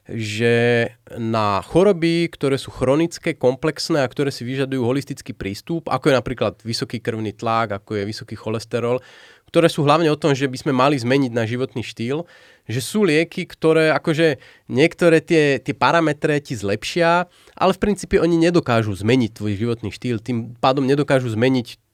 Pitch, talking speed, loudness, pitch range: 130 Hz, 165 wpm, -20 LUFS, 115-160 Hz